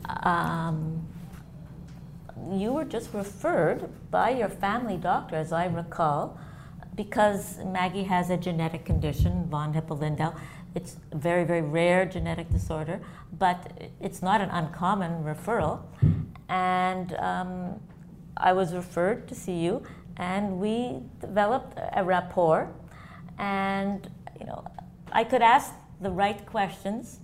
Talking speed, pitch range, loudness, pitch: 120 wpm, 165-195 Hz, -28 LUFS, 180 Hz